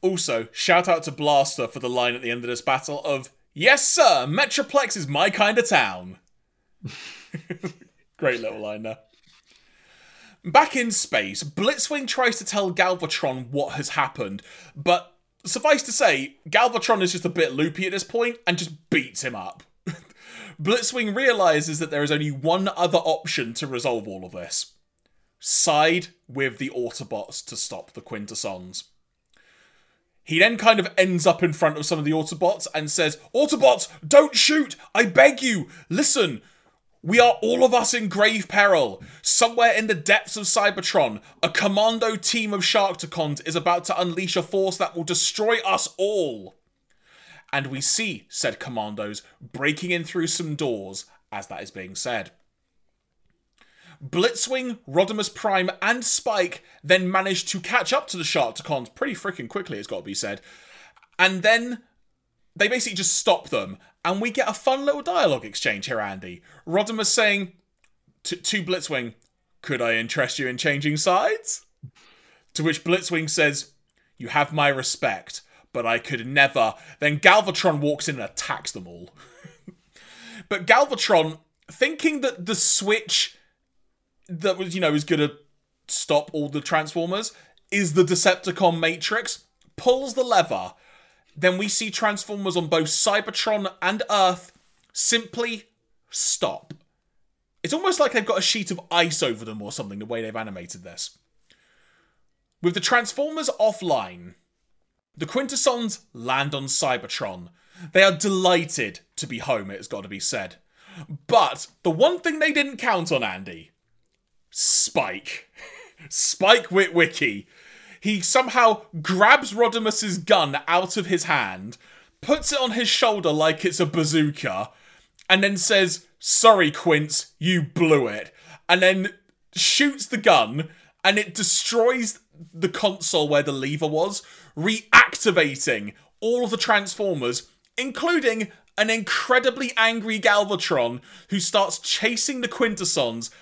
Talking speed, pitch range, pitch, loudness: 150 wpm, 155-225 Hz, 185 Hz, -21 LUFS